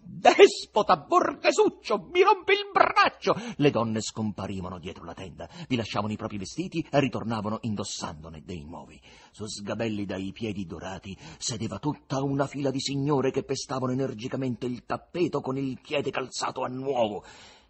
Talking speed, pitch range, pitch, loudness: 150 wpm, 105-150 Hz, 130 Hz, -27 LUFS